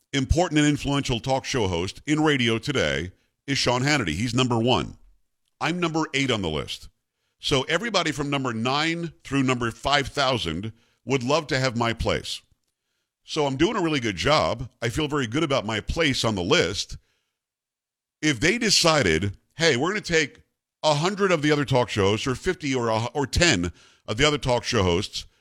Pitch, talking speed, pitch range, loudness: 130 Hz, 185 wpm, 115-150 Hz, -23 LUFS